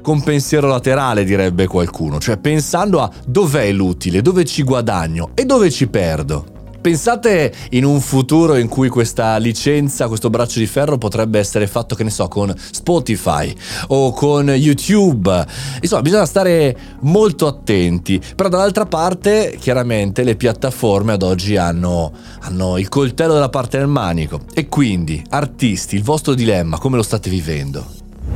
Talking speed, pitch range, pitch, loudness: 150 wpm, 95-145 Hz, 120 Hz, -15 LUFS